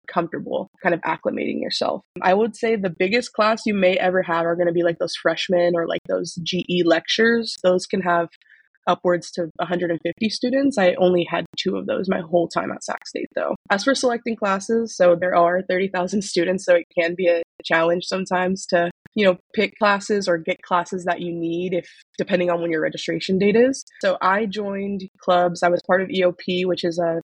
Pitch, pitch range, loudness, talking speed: 180 Hz, 175-200 Hz, -21 LUFS, 205 wpm